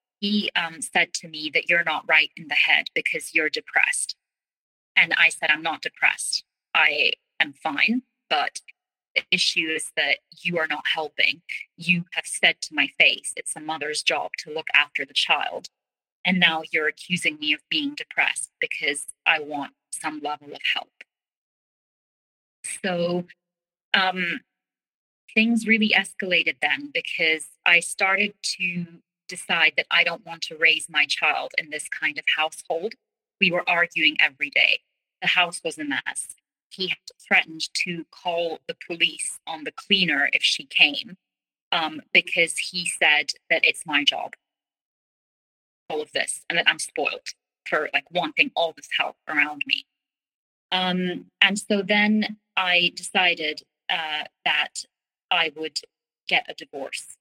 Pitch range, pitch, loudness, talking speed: 160-210 Hz, 175 Hz, -22 LUFS, 155 wpm